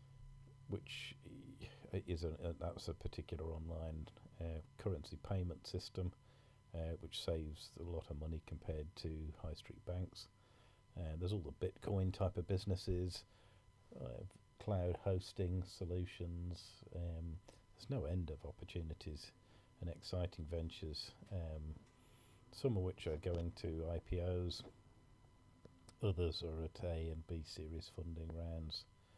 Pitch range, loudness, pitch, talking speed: 85-105 Hz, -46 LUFS, 90 Hz, 125 wpm